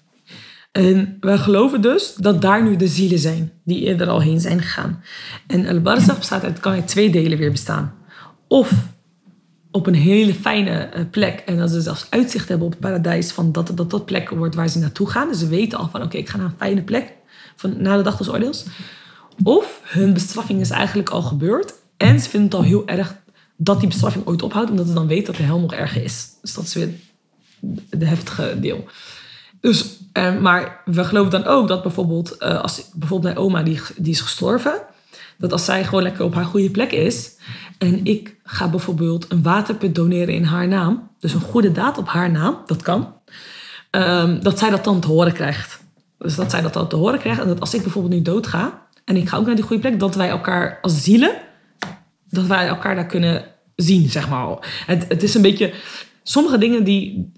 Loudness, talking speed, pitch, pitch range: -18 LUFS, 210 wpm, 185 Hz, 170-200 Hz